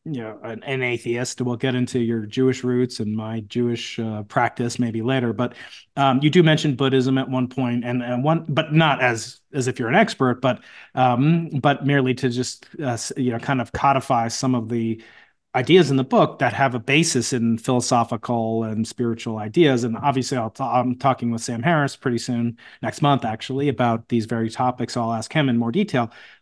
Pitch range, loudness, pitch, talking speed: 115-135 Hz, -21 LUFS, 125 Hz, 200 wpm